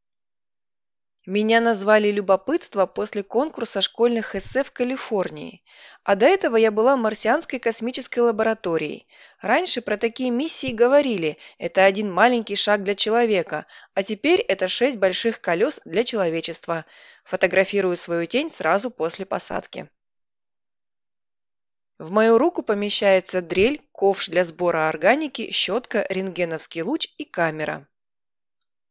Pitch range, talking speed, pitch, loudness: 180-240 Hz, 115 wpm, 205 Hz, -21 LUFS